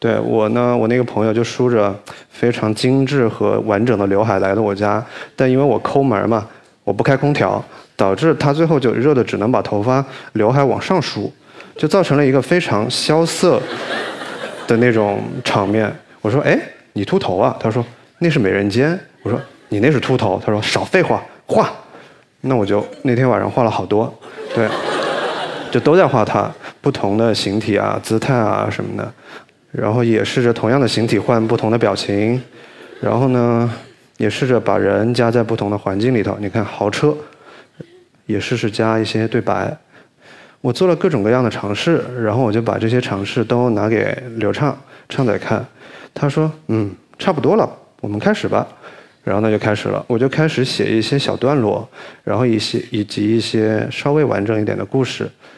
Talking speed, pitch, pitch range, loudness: 265 characters per minute, 115 Hz, 105-135 Hz, -17 LUFS